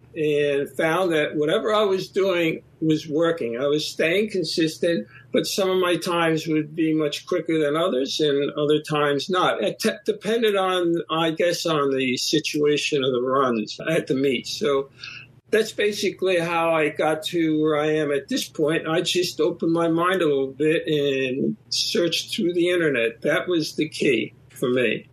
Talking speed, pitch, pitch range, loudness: 180 wpm, 155 Hz, 145-175 Hz, -22 LUFS